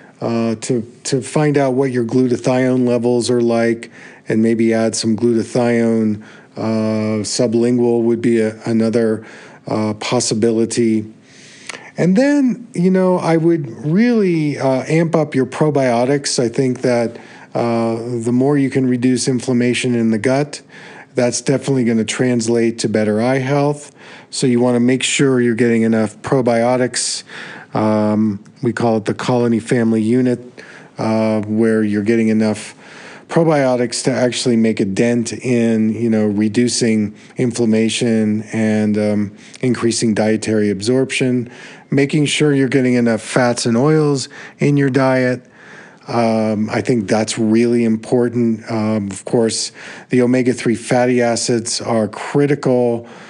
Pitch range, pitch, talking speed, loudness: 110-130 Hz, 120 Hz, 140 wpm, -16 LUFS